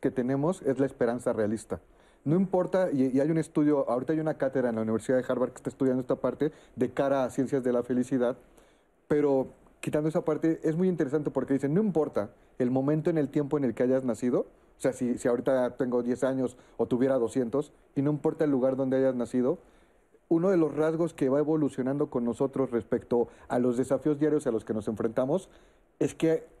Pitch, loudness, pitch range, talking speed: 135 Hz, -28 LUFS, 125-150 Hz, 215 wpm